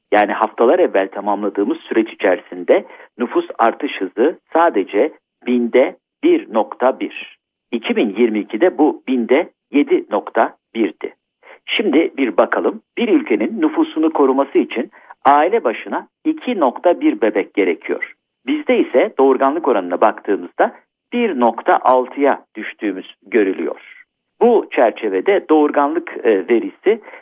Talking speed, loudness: 90 wpm, -17 LUFS